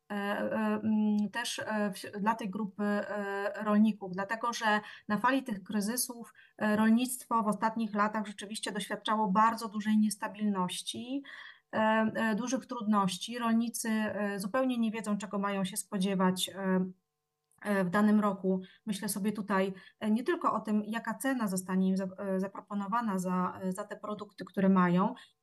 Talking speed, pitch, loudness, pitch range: 120 wpm, 210 Hz, -32 LUFS, 195-225 Hz